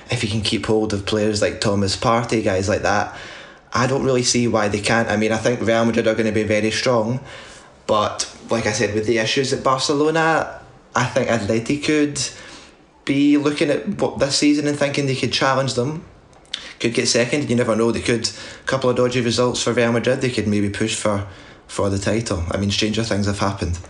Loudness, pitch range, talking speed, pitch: -19 LUFS, 110-130 Hz, 220 wpm, 115 Hz